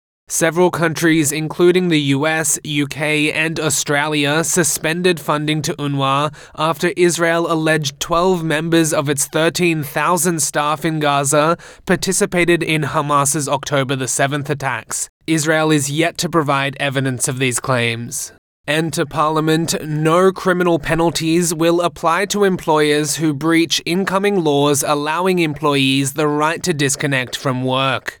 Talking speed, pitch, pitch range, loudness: 130 wpm, 155 Hz, 145-170 Hz, -16 LUFS